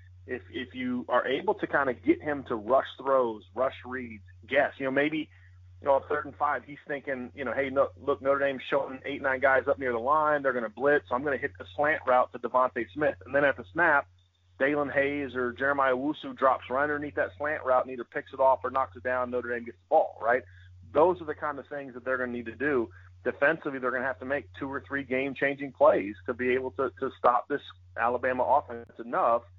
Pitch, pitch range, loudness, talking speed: 130 Hz, 120-140 Hz, -28 LUFS, 250 wpm